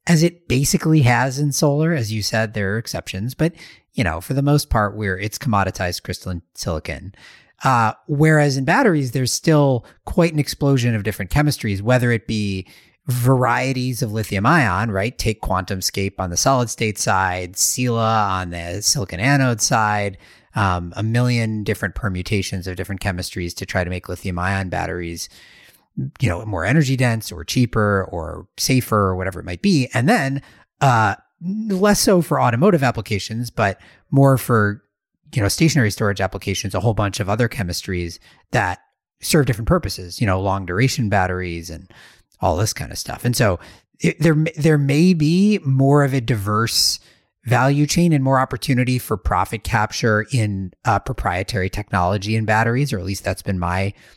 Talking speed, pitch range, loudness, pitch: 170 wpm, 95-135 Hz, -19 LUFS, 110 Hz